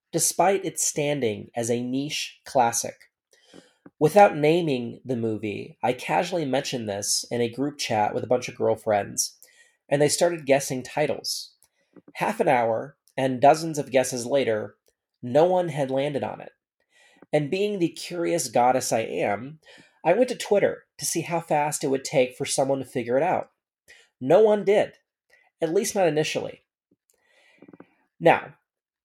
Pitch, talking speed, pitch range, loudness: 145 Hz, 155 wpm, 130-170 Hz, -24 LUFS